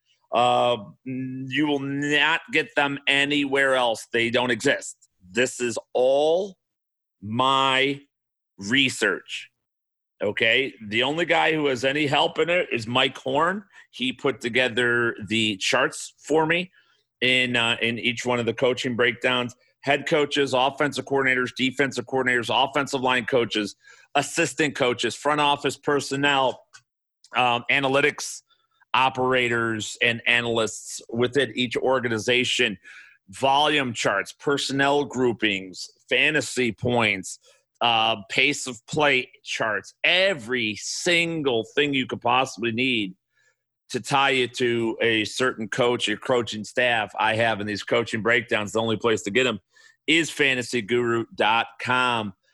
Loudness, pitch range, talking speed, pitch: -22 LUFS, 120-140 Hz, 125 wpm, 125 Hz